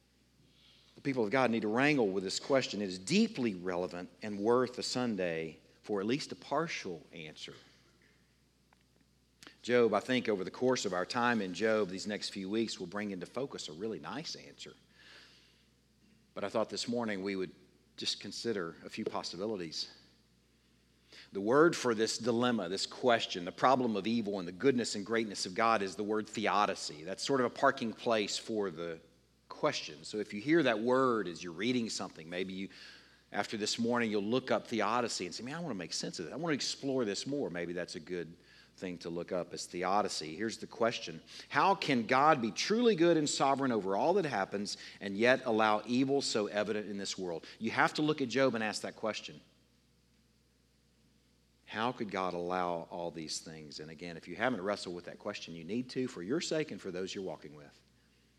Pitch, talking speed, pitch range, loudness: 105 Hz, 200 wpm, 90-125 Hz, -34 LUFS